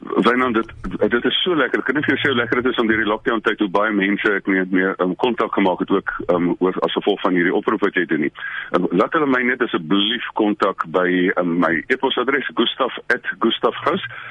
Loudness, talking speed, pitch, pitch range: -19 LUFS, 245 wpm, 100 Hz, 95-110 Hz